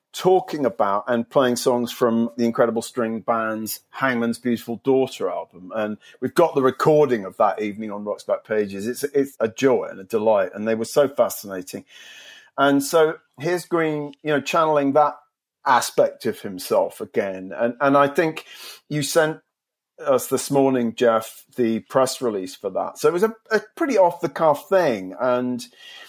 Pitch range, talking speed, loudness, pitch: 115-150 Hz, 175 wpm, -21 LUFS, 130 Hz